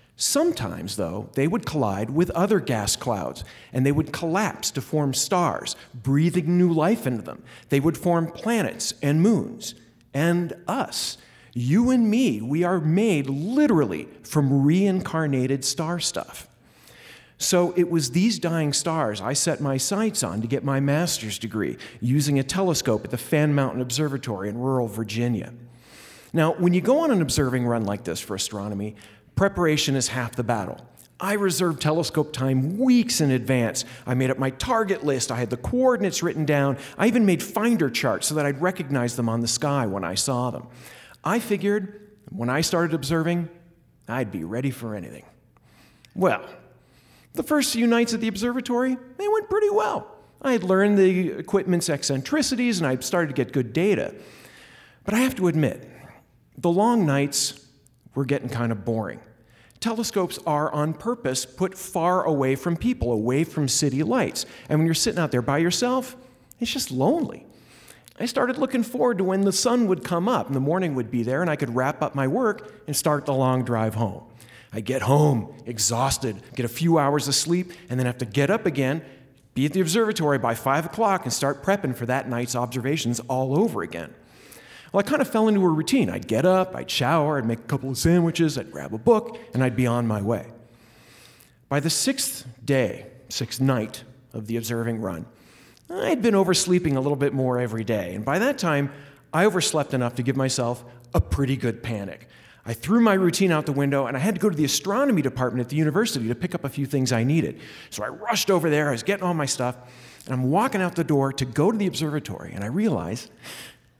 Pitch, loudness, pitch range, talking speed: 145 Hz, -23 LUFS, 125-185 Hz, 195 wpm